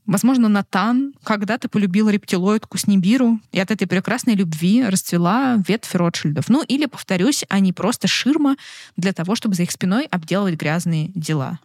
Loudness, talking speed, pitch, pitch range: -19 LUFS, 150 wpm, 200 Hz, 185-230 Hz